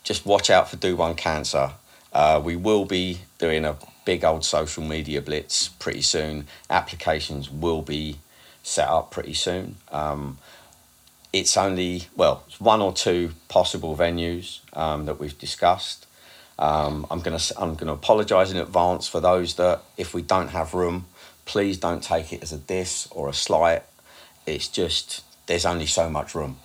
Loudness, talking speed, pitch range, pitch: -24 LUFS, 170 wpm, 75-90 Hz, 80 Hz